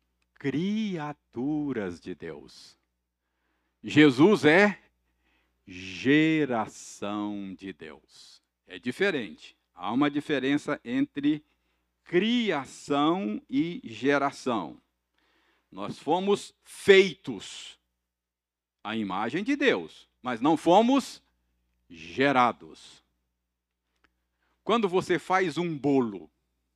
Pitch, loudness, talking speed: 120 Hz, -26 LUFS, 75 wpm